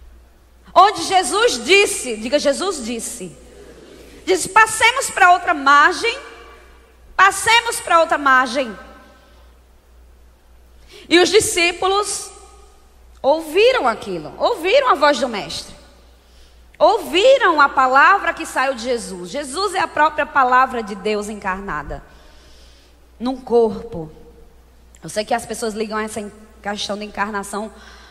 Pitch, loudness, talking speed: 260 Hz, -16 LUFS, 110 wpm